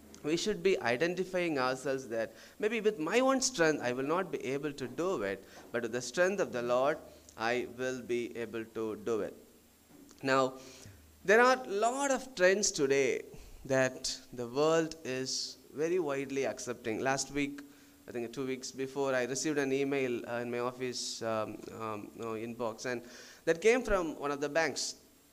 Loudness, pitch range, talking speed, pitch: -33 LUFS, 120-165 Hz, 175 wpm, 130 Hz